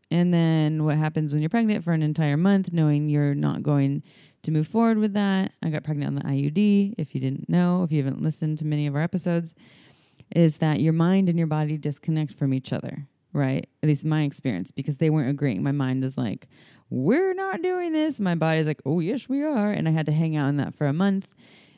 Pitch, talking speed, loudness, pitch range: 155 Hz, 235 wpm, -24 LUFS, 145-180 Hz